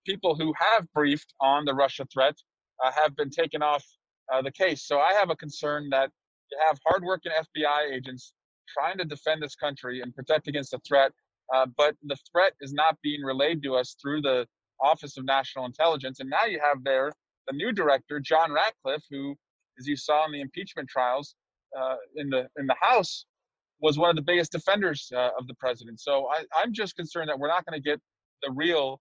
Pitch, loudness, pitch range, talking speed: 145 Hz, -27 LUFS, 135-155 Hz, 205 wpm